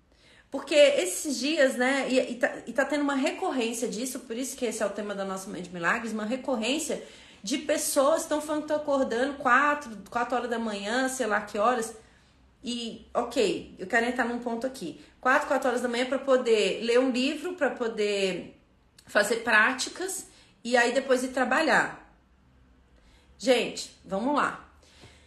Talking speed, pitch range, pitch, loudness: 175 wpm, 220-275 Hz, 250 Hz, -27 LUFS